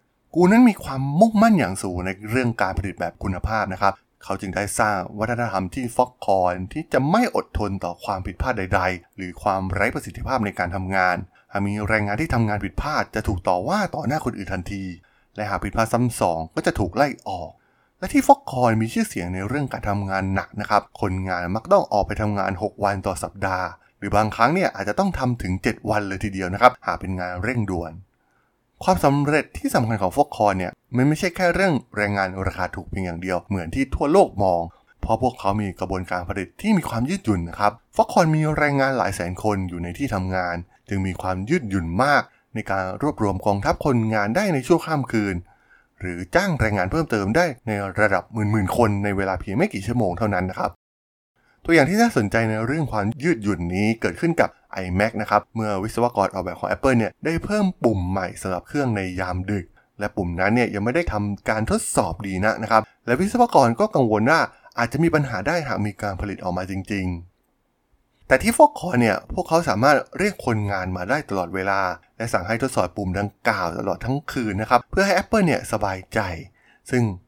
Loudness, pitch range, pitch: -22 LUFS, 95-125 Hz, 105 Hz